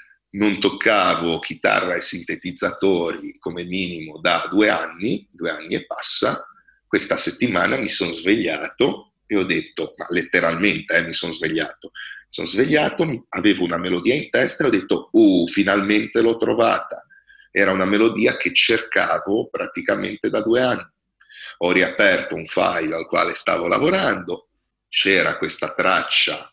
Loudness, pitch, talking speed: -19 LUFS, 250 Hz, 140 wpm